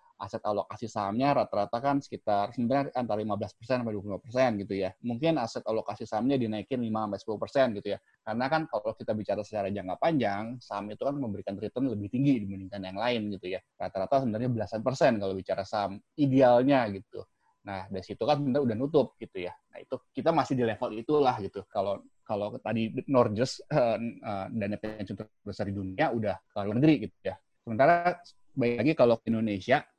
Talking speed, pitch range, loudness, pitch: 180 wpm, 100-130 Hz, -30 LUFS, 110 Hz